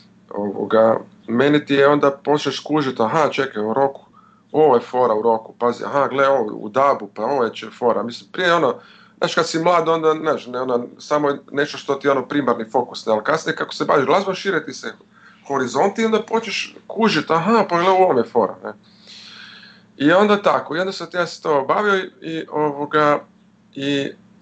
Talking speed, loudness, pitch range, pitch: 200 wpm, -19 LUFS, 140-190 Hz, 150 Hz